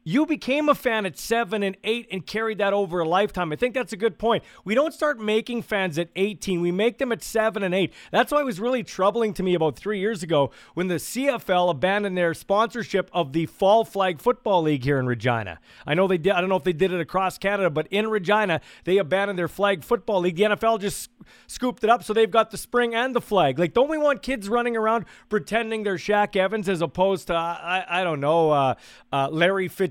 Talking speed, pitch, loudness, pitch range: 240 wpm, 200 Hz, -23 LUFS, 180-225 Hz